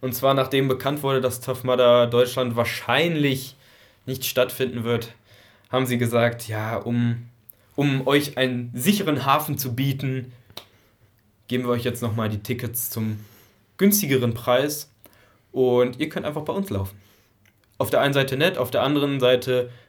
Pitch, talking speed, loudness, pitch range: 125 Hz, 155 wpm, -23 LUFS, 115-135 Hz